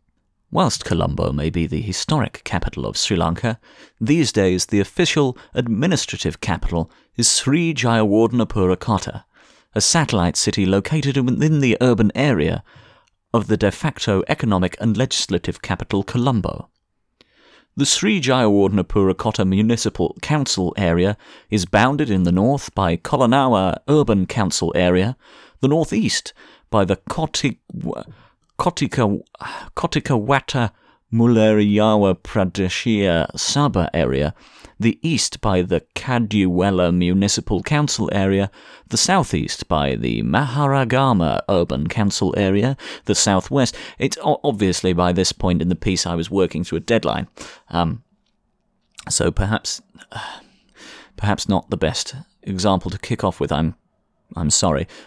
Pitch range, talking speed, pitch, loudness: 90-120 Hz, 120 wpm, 100 Hz, -19 LUFS